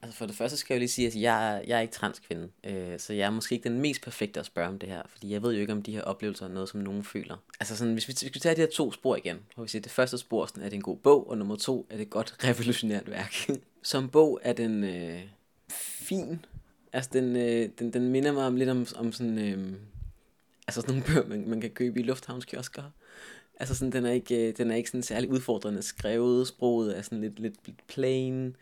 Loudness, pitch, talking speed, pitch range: -30 LUFS, 115 Hz, 260 wpm, 105-125 Hz